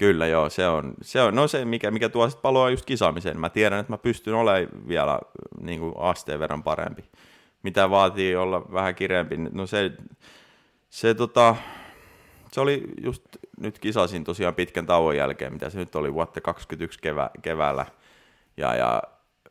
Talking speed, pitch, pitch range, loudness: 165 wpm, 100 Hz, 90-115 Hz, -24 LUFS